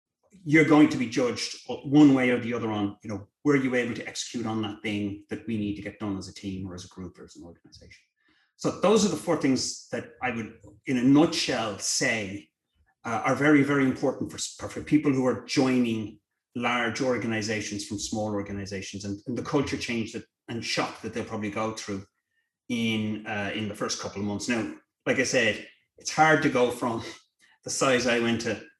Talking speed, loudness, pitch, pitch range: 215 wpm, -26 LUFS, 115 Hz, 105-130 Hz